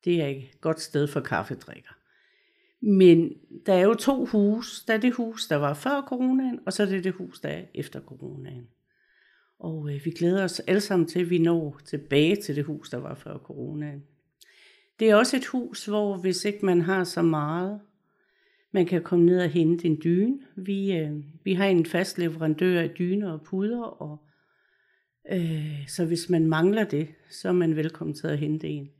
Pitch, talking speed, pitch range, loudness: 175 Hz, 200 wpm, 155-205 Hz, -25 LUFS